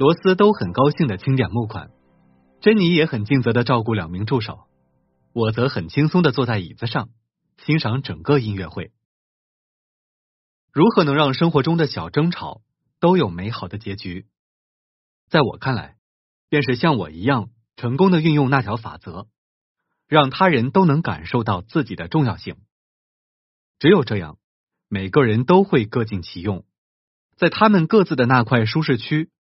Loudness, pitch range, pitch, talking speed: -19 LUFS, 105-150 Hz, 125 Hz, 240 characters per minute